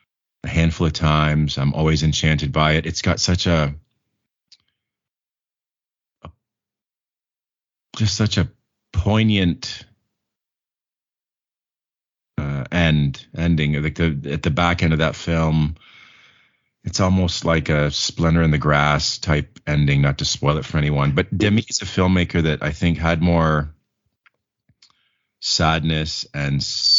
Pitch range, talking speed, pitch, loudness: 75-90 Hz, 125 wpm, 80 Hz, -19 LUFS